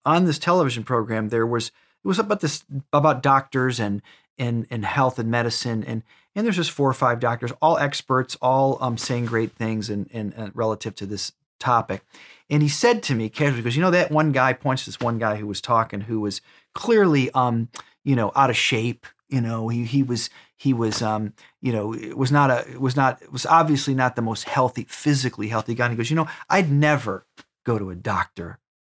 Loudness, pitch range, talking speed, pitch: -22 LUFS, 115-140 Hz, 210 wpm, 125 Hz